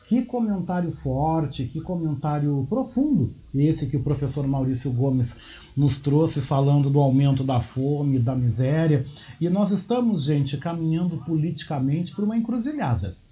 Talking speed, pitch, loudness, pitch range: 135 wpm, 145 Hz, -23 LUFS, 135-170 Hz